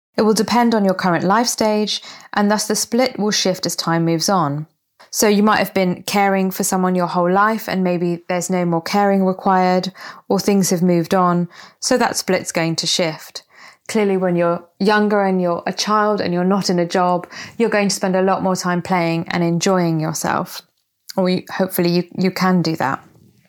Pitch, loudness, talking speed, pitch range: 185 Hz, -17 LUFS, 205 wpm, 175-205 Hz